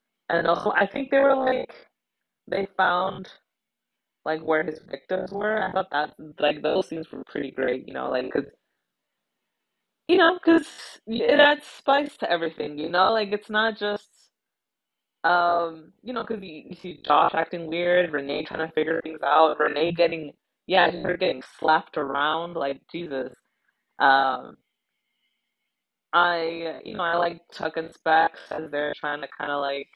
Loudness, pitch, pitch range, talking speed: -24 LUFS, 170 Hz, 155-205 Hz, 160 wpm